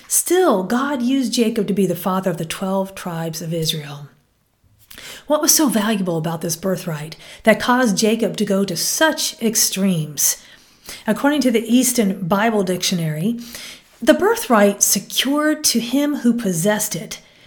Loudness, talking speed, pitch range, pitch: -18 LUFS, 150 wpm, 175-245 Hz, 205 Hz